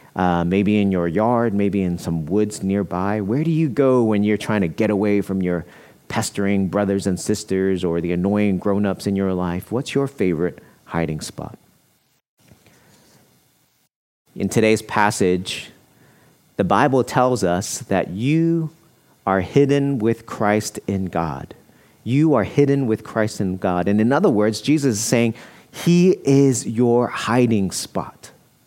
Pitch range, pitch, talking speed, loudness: 95-120 Hz, 105 Hz, 155 wpm, -20 LUFS